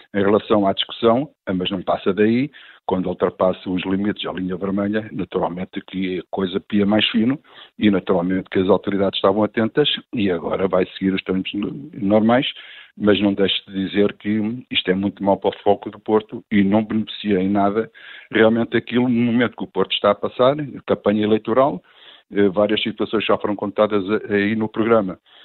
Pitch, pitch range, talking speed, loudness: 105 Hz, 95-110 Hz, 180 wpm, -20 LUFS